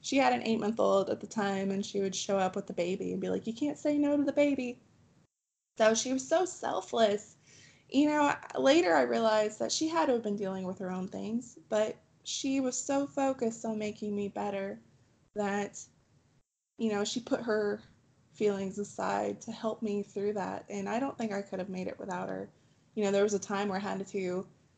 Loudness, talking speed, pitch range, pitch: -32 LUFS, 220 wpm, 195-245 Hz, 210 Hz